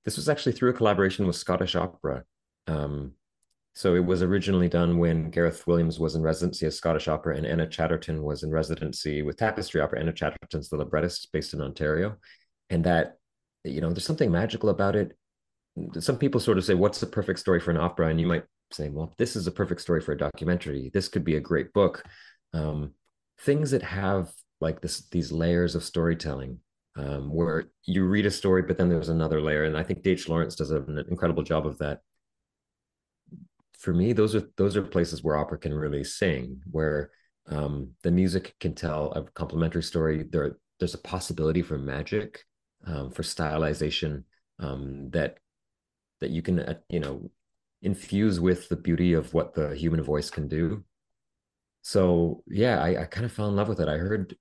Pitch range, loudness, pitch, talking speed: 75-90 Hz, -27 LUFS, 85 Hz, 190 wpm